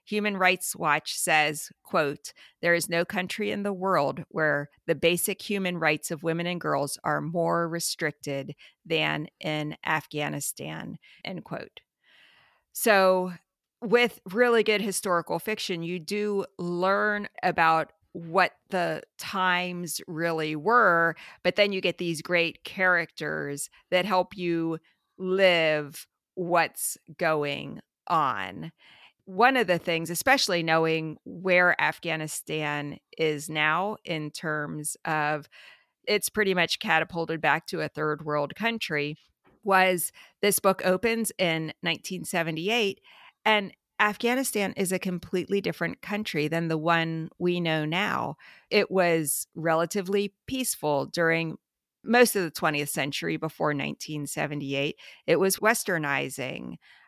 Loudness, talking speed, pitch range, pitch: -26 LUFS, 120 wpm, 155-195 Hz, 170 Hz